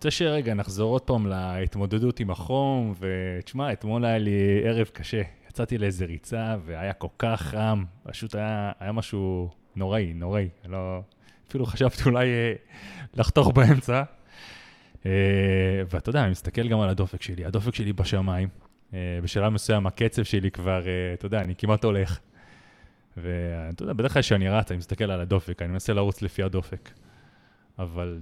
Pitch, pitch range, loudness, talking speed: 100 Hz, 95-110 Hz, -26 LUFS, 150 wpm